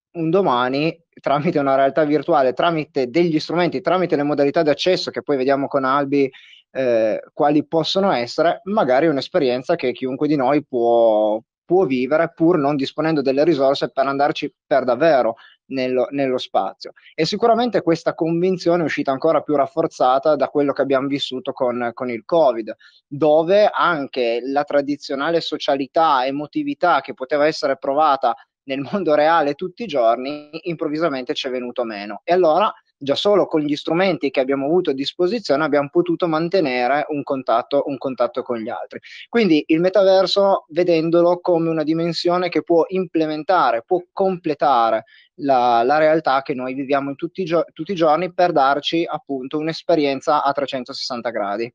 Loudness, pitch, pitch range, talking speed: -19 LUFS, 150 Hz, 135-170 Hz, 160 wpm